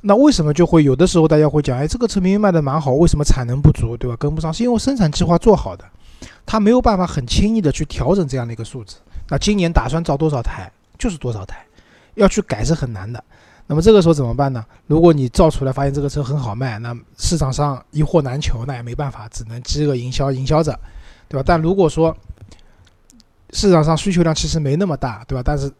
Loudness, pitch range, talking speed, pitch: -17 LUFS, 120-170 Hz, 360 characters per minute, 145 Hz